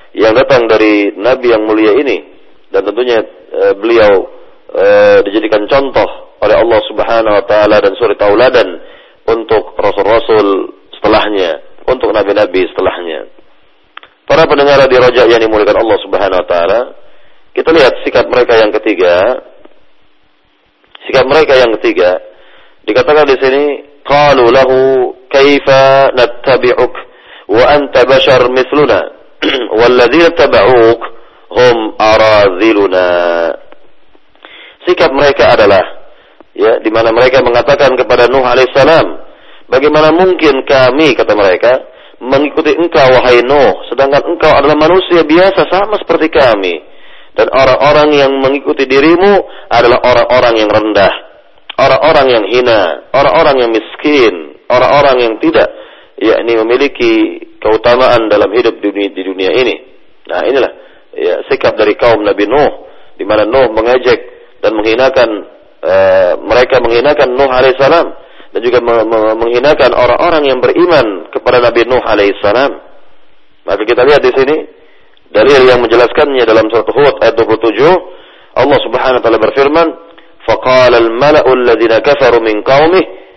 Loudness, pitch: -8 LUFS, 145 Hz